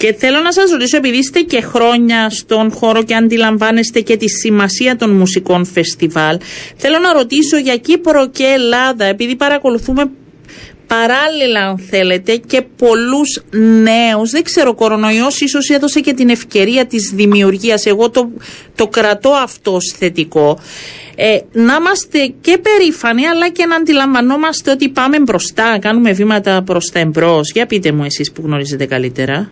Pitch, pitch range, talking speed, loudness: 230 Hz, 200-275 Hz, 155 wpm, -11 LUFS